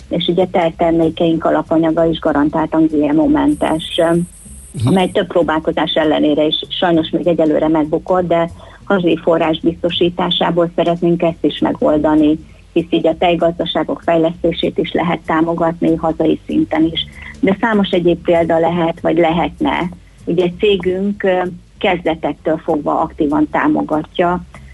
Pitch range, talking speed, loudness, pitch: 160-180 Hz, 120 wpm, -15 LUFS, 165 Hz